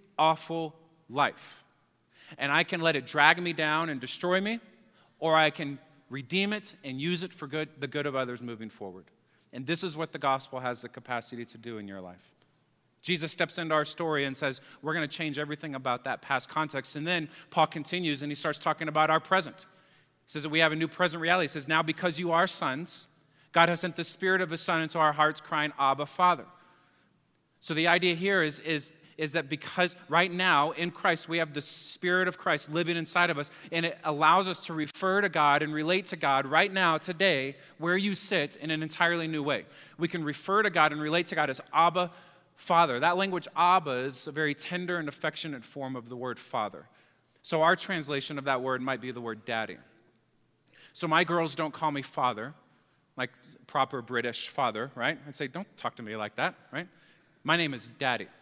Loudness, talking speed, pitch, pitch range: -29 LUFS, 215 wpm, 155 Hz, 140-170 Hz